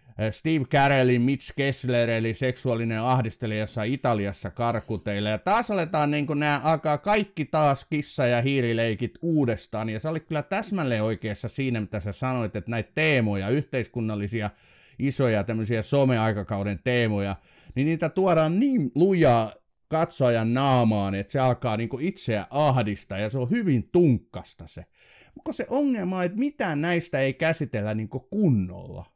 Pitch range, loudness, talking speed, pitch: 110-150 Hz, -25 LUFS, 145 wpm, 130 Hz